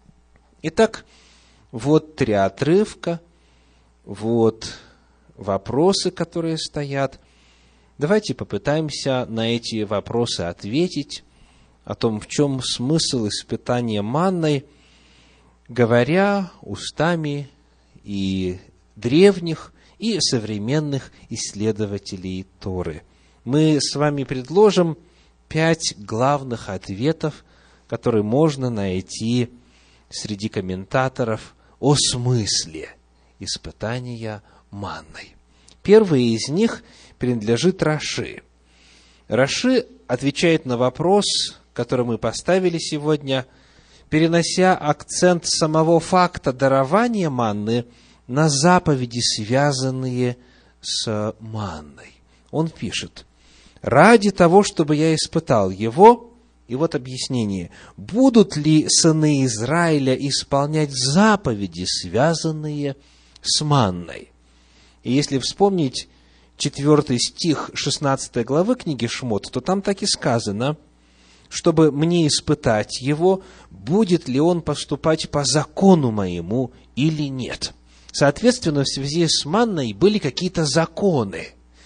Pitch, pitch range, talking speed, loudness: 130 Hz, 100-160 Hz, 90 wpm, -20 LUFS